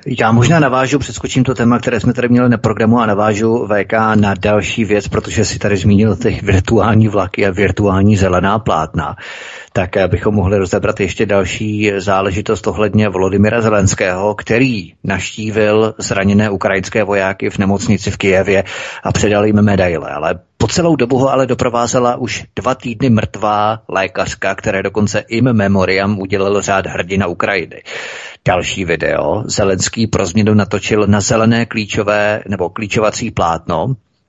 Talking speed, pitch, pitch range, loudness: 145 wpm, 105 Hz, 100-115 Hz, -14 LUFS